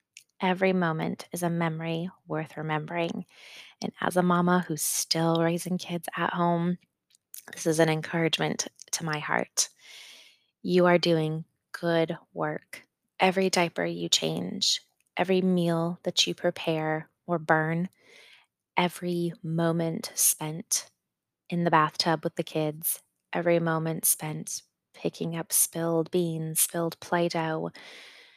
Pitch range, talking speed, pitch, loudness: 160-180 Hz, 125 wpm, 170 Hz, -27 LUFS